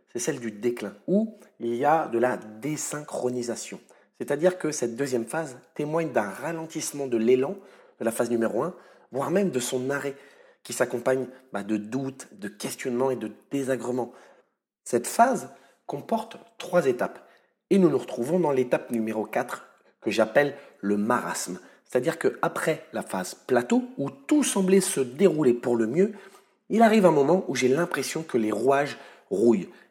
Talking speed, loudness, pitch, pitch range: 165 wpm, -26 LUFS, 135 Hz, 120-165 Hz